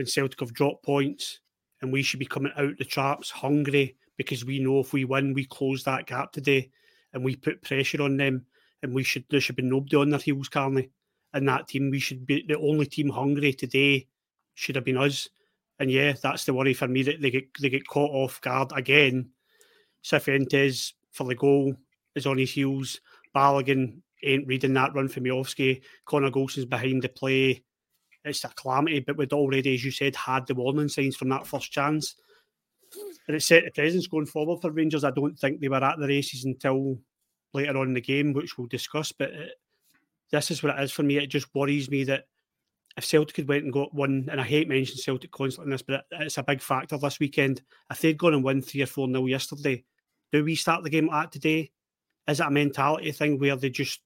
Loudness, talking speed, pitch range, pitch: -26 LUFS, 220 wpm, 135-145 Hz, 140 Hz